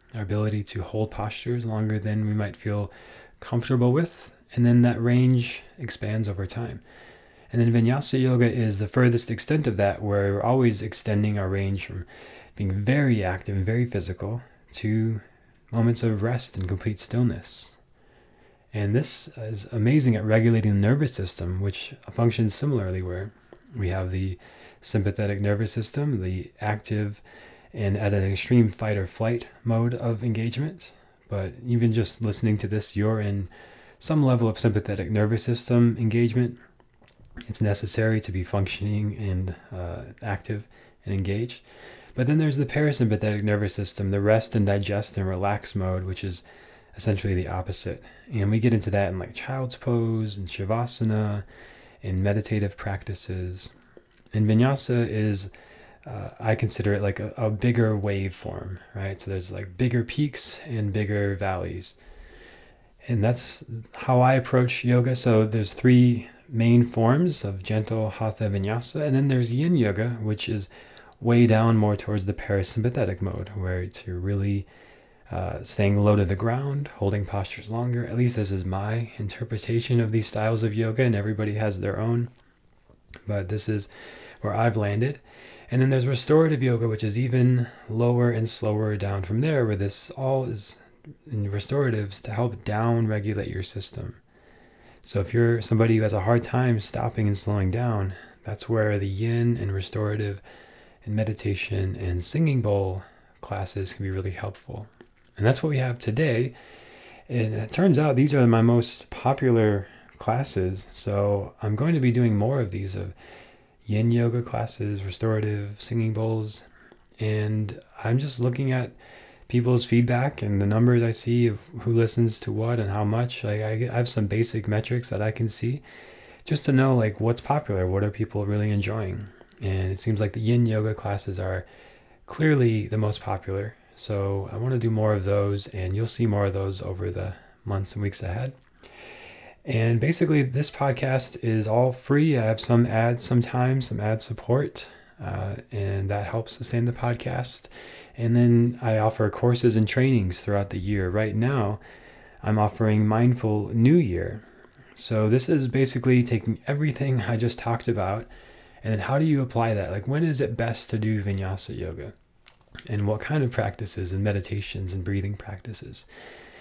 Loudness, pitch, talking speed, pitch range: -25 LUFS, 110 Hz, 165 wpm, 100-120 Hz